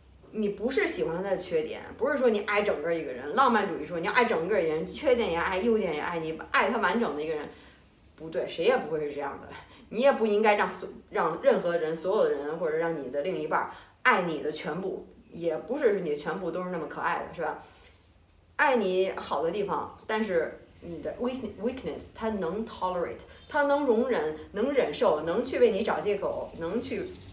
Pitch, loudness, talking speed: 220 Hz, -28 LUFS, 325 characters per minute